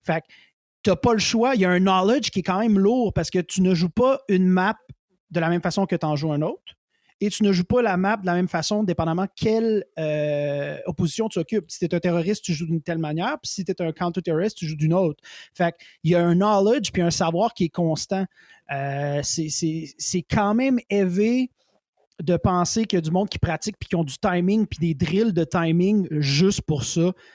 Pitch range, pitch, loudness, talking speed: 165-205 Hz, 180 Hz, -22 LUFS, 250 wpm